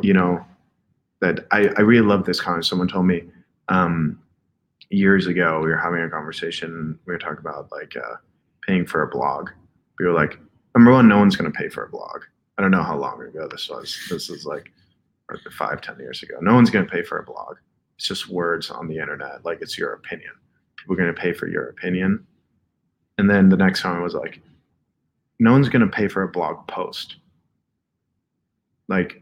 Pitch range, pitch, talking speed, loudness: 85-100 Hz, 90 Hz, 205 wpm, -20 LUFS